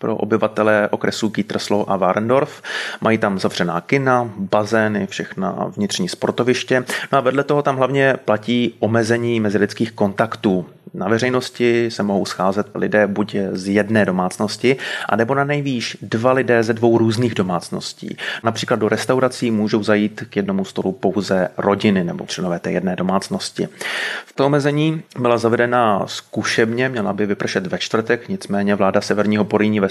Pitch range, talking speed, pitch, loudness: 105-125 Hz, 145 wpm, 115 Hz, -19 LUFS